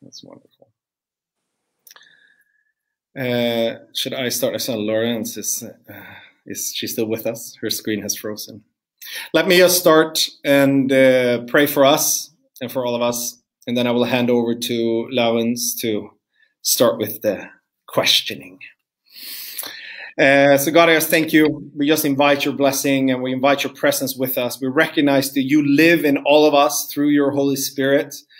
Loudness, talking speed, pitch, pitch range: -17 LUFS, 165 wpm, 140 Hz, 120-155 Hz